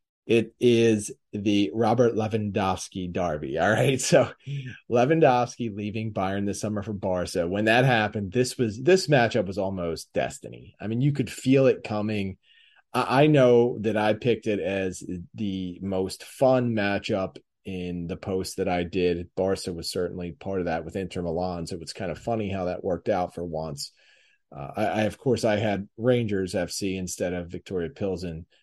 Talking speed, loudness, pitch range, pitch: 180 wpm, -26 LUFS, 90-115 Hz, 100 Hz